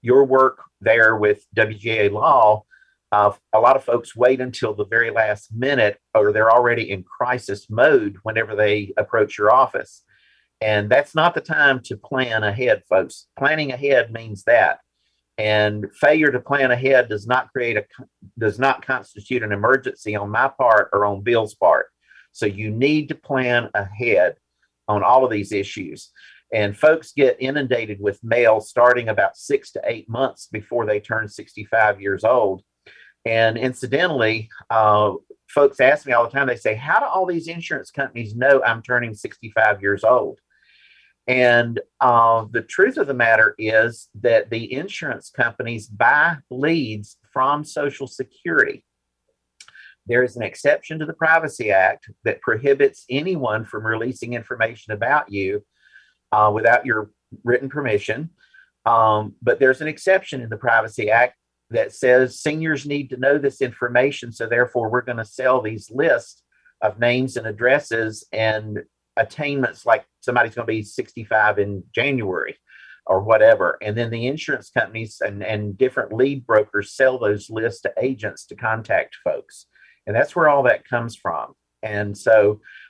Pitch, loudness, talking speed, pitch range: 120 Hz, -19 LUFS, 160 wpm, 105-130 Hz